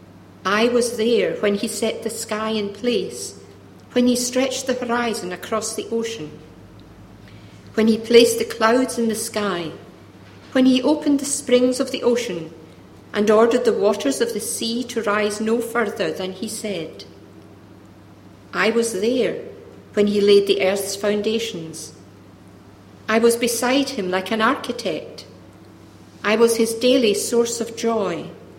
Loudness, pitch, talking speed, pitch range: -20 LUFS, 220 Hz, 150 wpm, 175-235 Hz